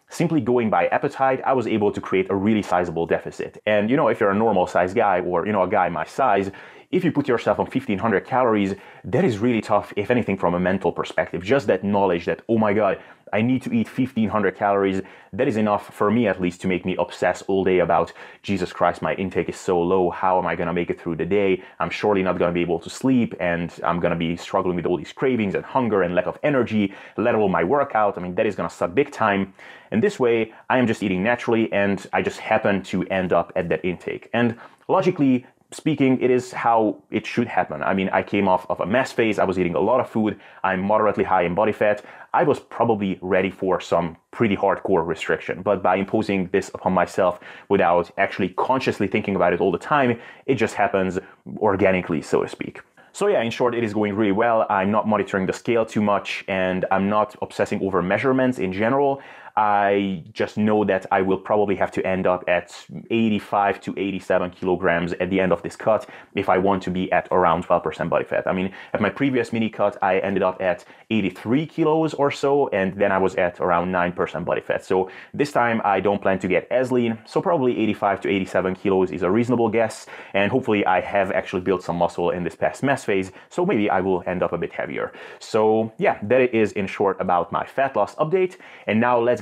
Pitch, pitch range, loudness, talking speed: 100 Hz, 95-115 Hz, -22 LUFS, 230 wpm